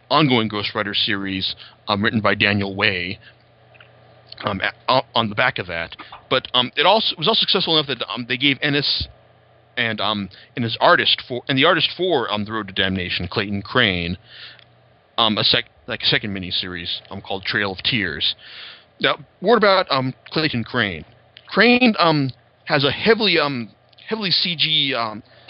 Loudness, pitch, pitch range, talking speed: -19 LUFS, 115 Hz, 100-145 Hz, 175 wpm